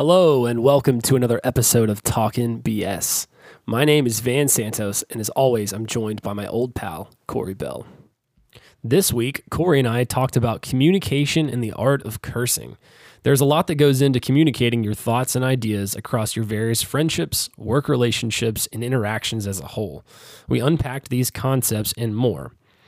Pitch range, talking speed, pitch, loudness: 110-135 Hz, 175 wpm, 120 Hz, -20 LUFS